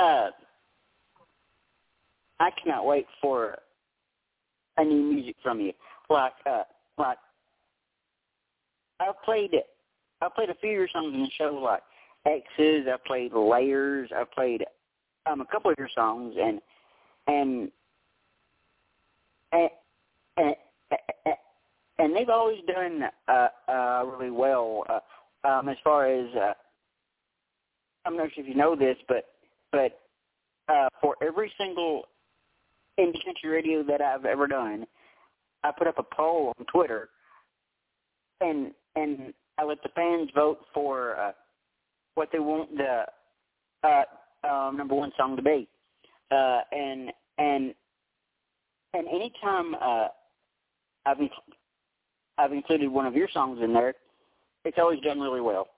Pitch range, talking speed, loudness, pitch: 135-170 Hz, 130 wpm, -28 LUFS, 150 Hz